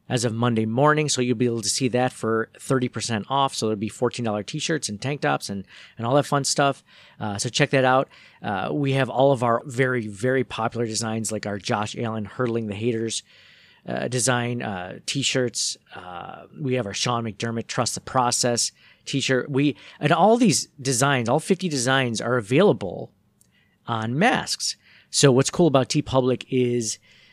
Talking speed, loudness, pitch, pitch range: 185 wpm, -23 LUFS, 125 Hz, 110-135 Hz